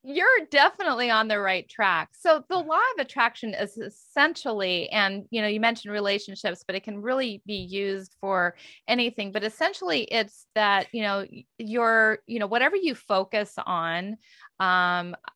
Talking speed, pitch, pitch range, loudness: 160 wpm, 215 Hz, 200-240 Hz, -25 LUFS